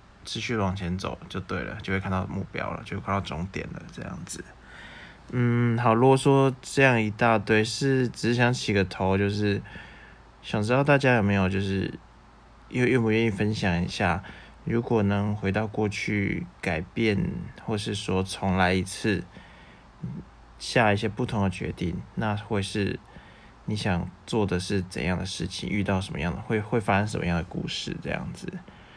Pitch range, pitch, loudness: 95-115 Hz, 100 Hz, -26 LUFS